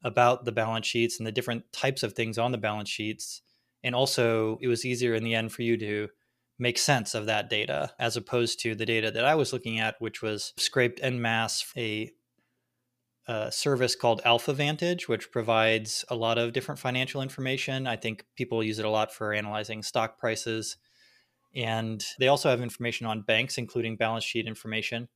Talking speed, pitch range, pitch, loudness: 195 wpm, 110-125 Hz, 115 Hz, -28 LUFS